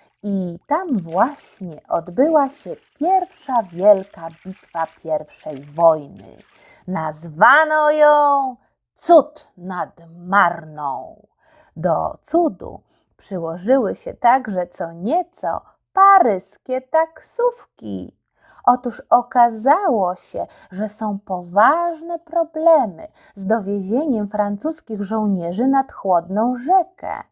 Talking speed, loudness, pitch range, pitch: 85 wpm, -19 LUFS, 185-300 Hz, 220 Hz